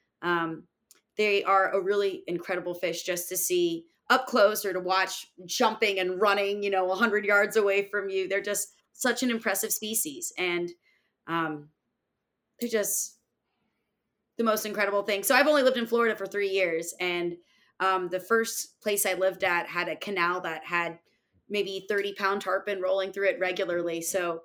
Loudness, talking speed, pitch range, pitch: -27 LUFS, 170 wpm, 185-215 Hz, 200 Hz